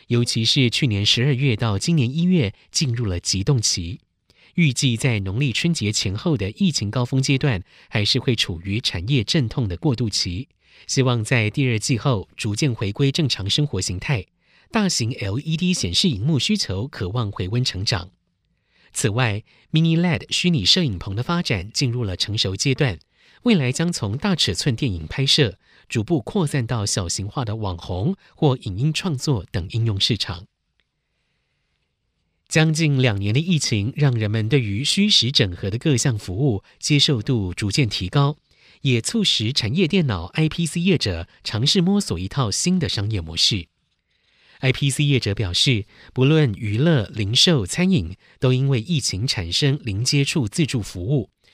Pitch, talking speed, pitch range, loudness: 125 Hz, 255 characters per minute, 105-150 Hz, -21 LUFS